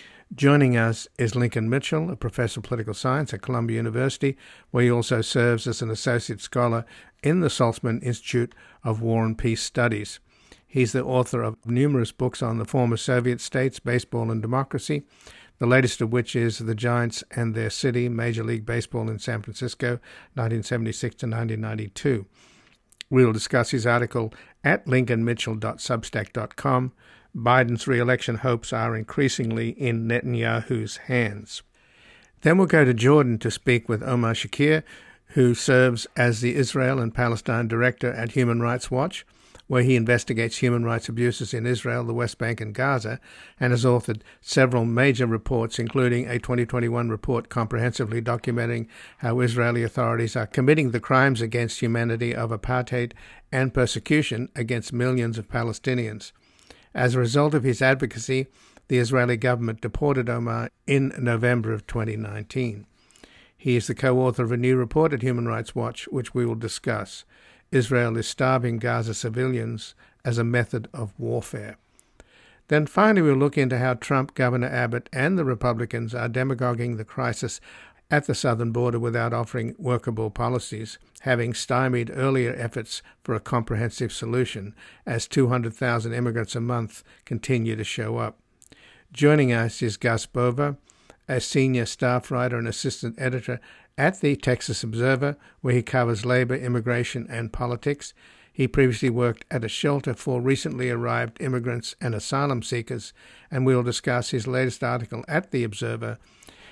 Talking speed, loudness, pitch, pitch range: 150 wpm, -24 LUFS, 120 Hz, 115-130 Hz